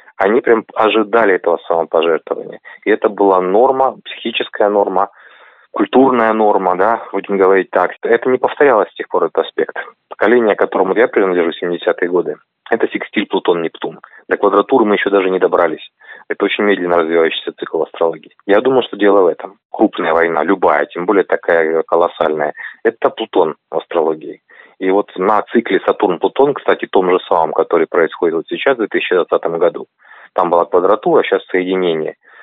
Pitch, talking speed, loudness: 115 Hz, 155 wpm, -14 LUFS